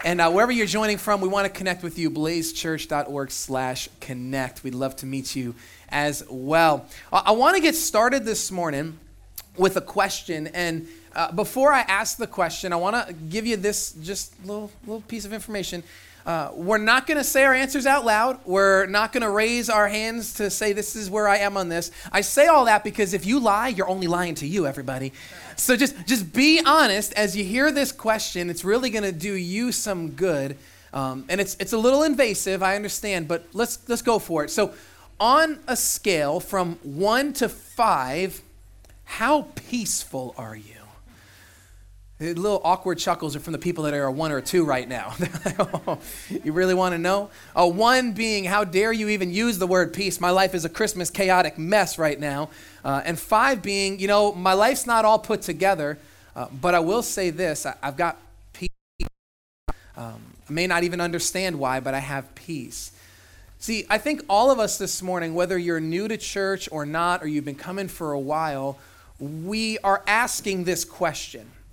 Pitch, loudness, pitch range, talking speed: 185 Hz, -23 LUFS, 155-215 Hz, 200 wpm